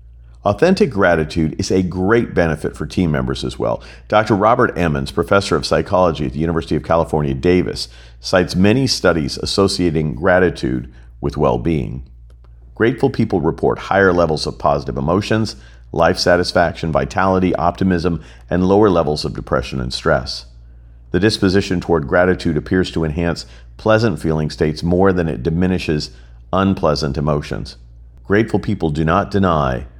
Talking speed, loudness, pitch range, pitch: 140 wpm, -17 LUFS, 65-95 Hz, 80 Hz